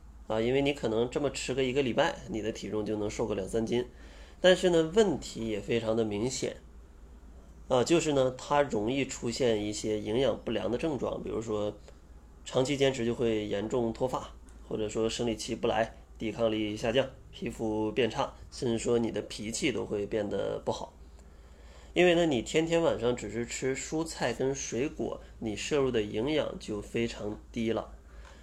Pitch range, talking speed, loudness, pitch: 100-130 Hz, 260 characters per minute, -31 LUFS, 115 Hz